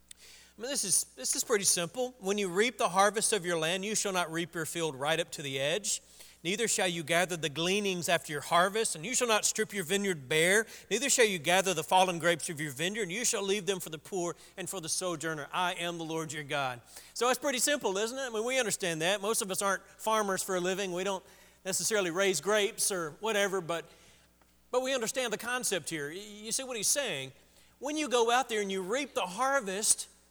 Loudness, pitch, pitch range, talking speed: -30 LUFS, 190 Hz, 170-220 Hz, 240 wpm